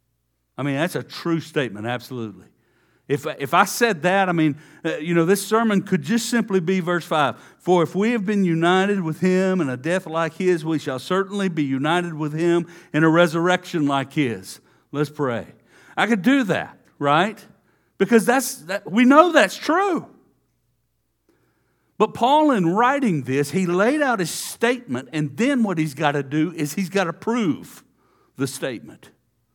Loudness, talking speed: -21 LUFS, 180 wpm